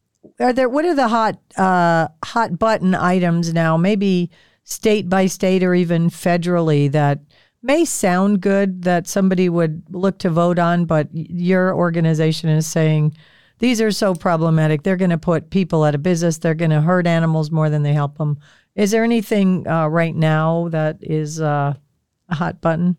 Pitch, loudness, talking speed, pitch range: 175 Hz, -18 LUFS, 175 wpm, 160-190 Hz